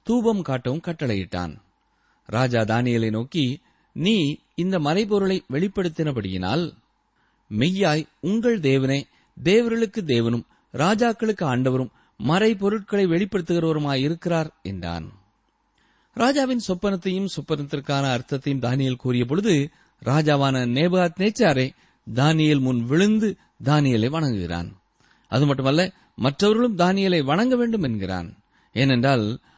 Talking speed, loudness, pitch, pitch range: 85 wpm, -22 LUFS, 150 Hz, 125-190 Hz